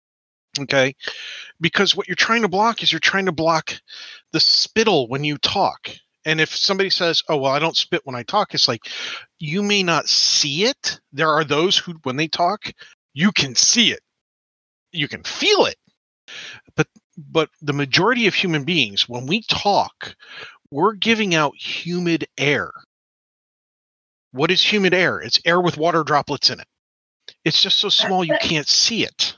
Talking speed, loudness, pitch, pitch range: 175 wpm, -18 LUFS, 165 Hz, 145-200 Hz